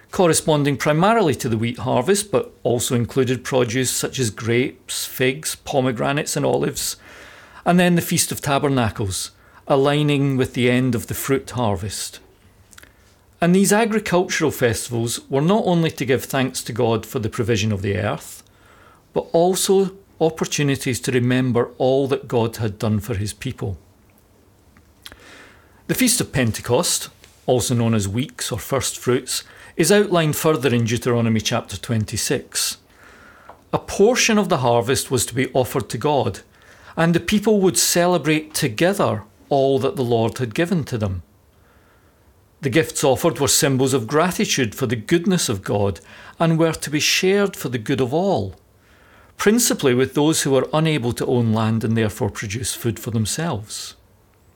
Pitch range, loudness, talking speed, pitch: 110-155 Hz, -20 LUFS, 155 wpm, 130 Hz